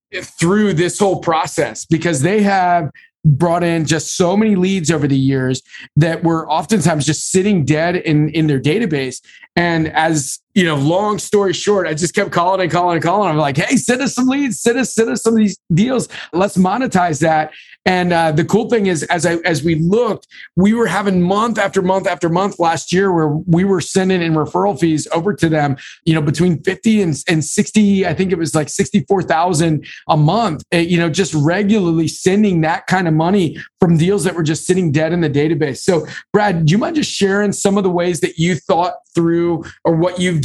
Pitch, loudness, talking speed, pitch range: 175 Hz, -15 LUFS, 210 wpm, 160-195 Hz